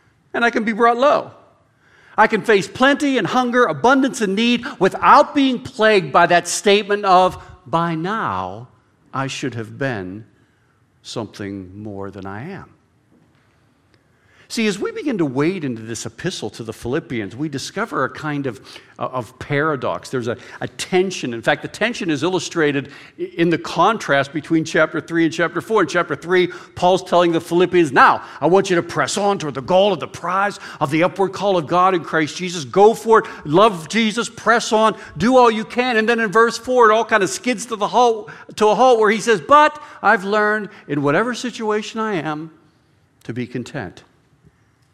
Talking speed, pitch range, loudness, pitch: 190 wpm, 140-220 Hz, -17 LUFS, 180 Hz